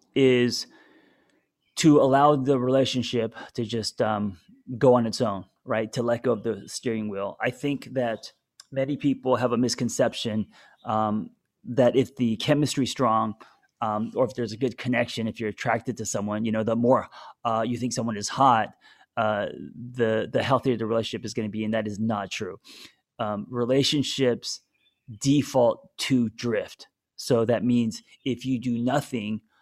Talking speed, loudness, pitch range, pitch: 170 wpm, -25 LUFS, 110-130 Hz, 120 Hz